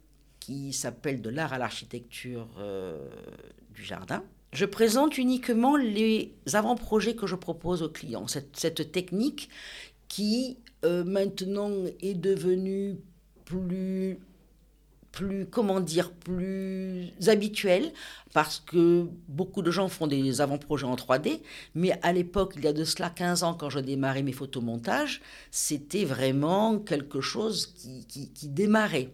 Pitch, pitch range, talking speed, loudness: 175 Hz, 145-195 Hz, 135 wpm, -29 LUFS